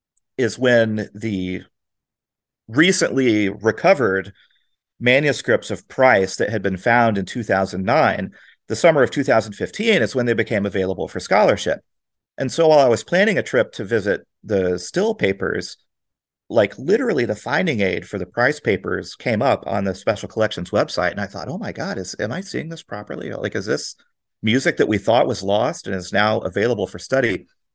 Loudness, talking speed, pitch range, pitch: -19 LUFS, 175 wpm, 95-120 Hz, 105 Hz